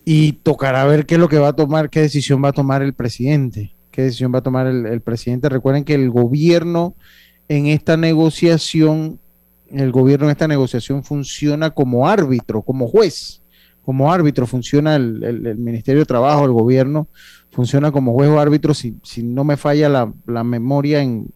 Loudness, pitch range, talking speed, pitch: -16 LUFS, 120-150 Hz, 190 wpm, 140 Hz